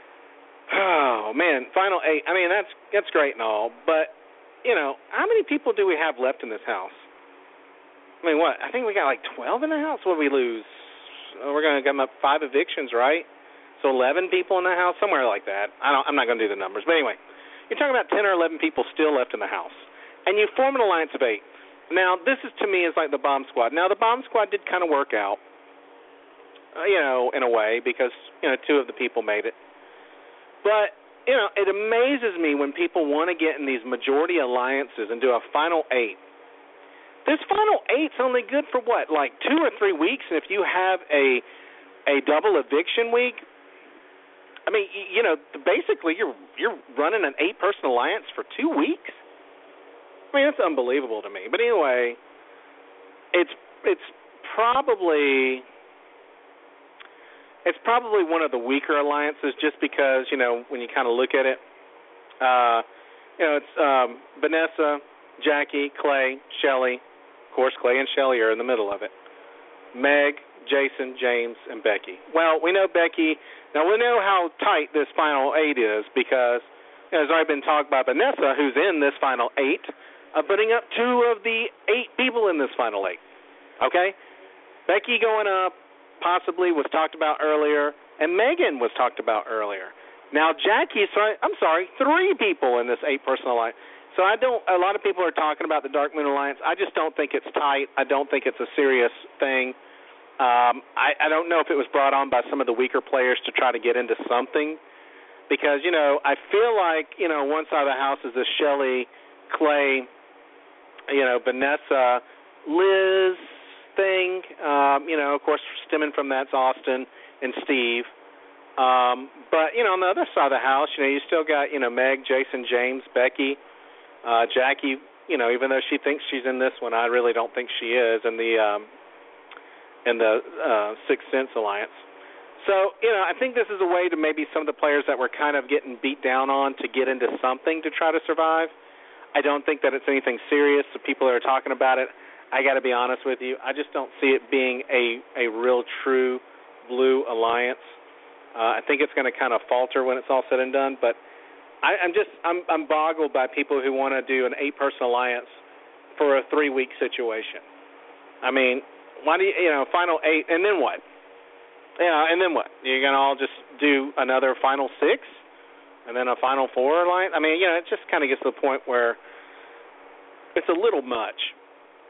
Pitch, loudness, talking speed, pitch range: 145 Hz, -23 LUFS, 200 wpm, 130-185 Hz